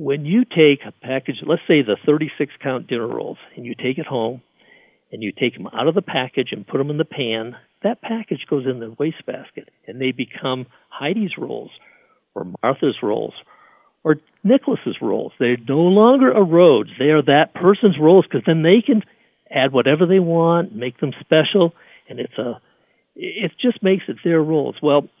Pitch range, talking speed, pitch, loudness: 135-195 Hz, 190 wpm, 155 Hz, -18 LUFS